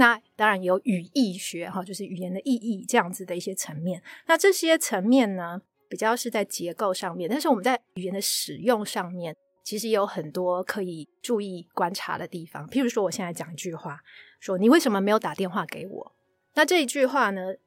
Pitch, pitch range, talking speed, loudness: 195 Hz, 180-235 Hz, 315 characters per minute, -26 LUFS